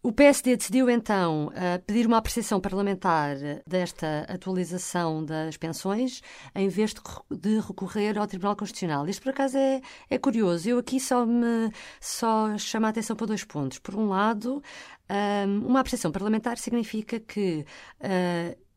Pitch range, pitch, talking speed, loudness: 180-235 Hz, 210 Hz, 135 wpm, -27 LUFS